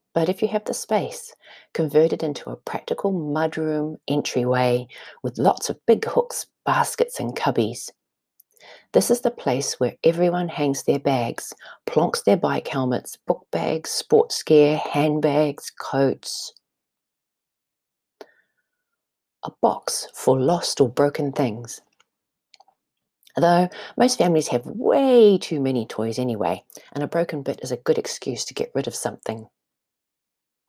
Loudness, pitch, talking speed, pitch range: -22 LUFS, 155 Hz, 135 wpm, 140-210 Hz